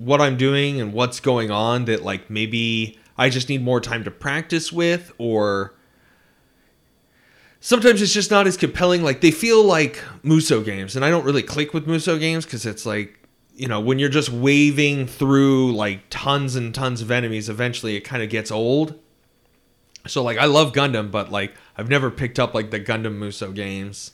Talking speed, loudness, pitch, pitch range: 190 wpm, -20 LUFS, 125 Hz, 110-145 Hz